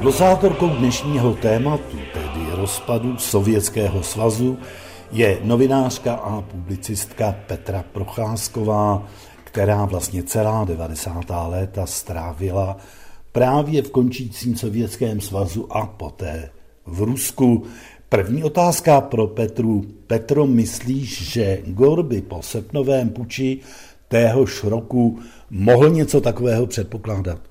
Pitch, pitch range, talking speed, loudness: 110 Hz, 95-125 Hz, 100 wpm, -20 LUFS